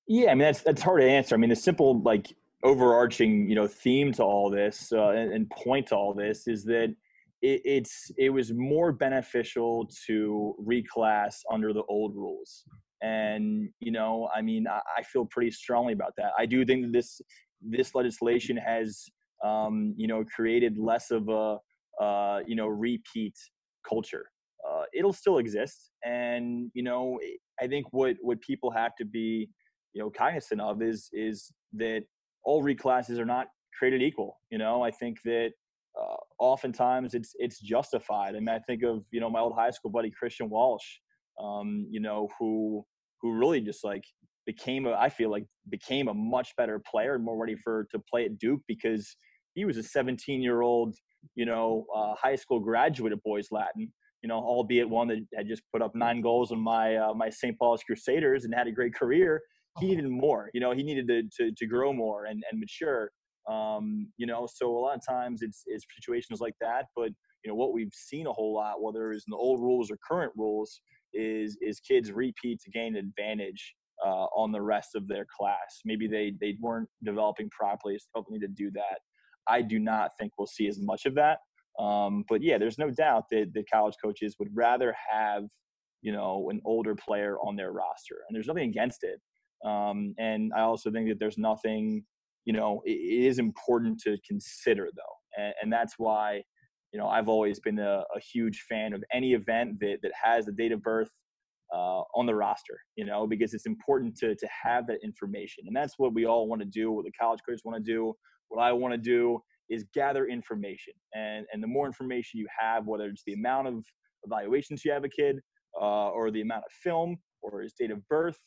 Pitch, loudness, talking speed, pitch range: 115 Hz, -30 LUFS, 205 wpm, 110-130 Hz